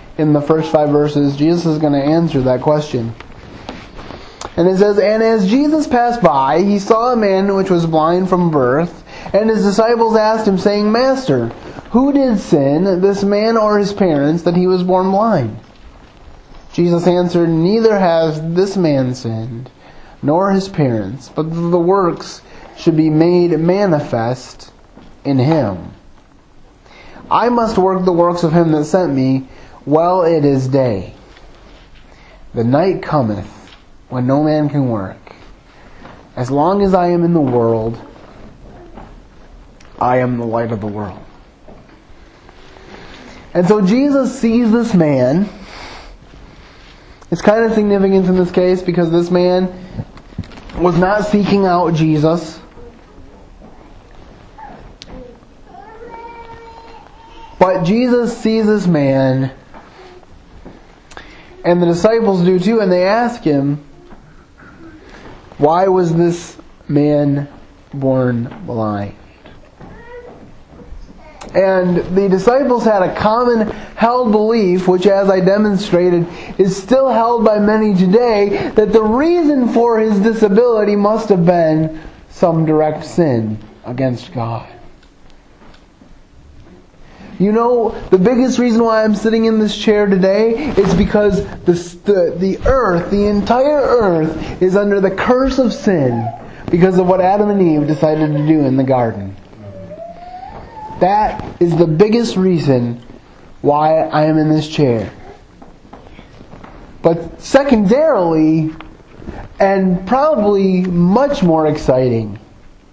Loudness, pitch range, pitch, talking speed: -14 LUFS, 145-210 Hz, 180 Hz, 125 wpm